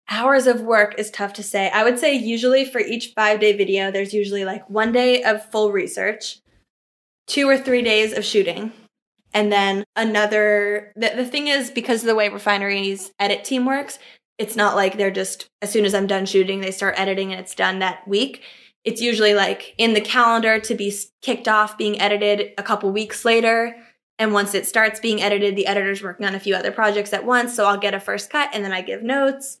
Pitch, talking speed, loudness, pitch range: 210 Hz, 215 wpm, -19 LUFS, 200-230 Hz